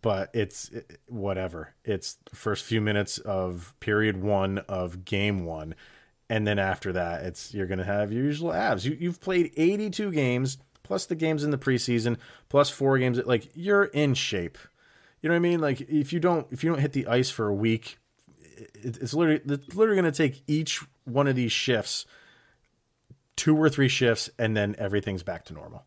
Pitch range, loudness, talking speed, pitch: 105-150 Hz, -27 LUFS, 195 wpm, 125 Hz